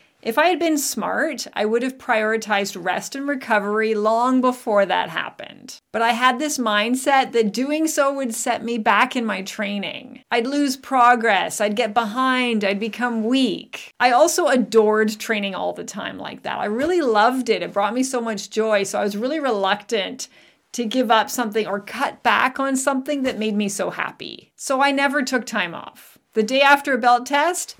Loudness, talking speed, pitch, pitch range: -20 LUFS, 195 wpm, 240 Hz, 215-270 Hz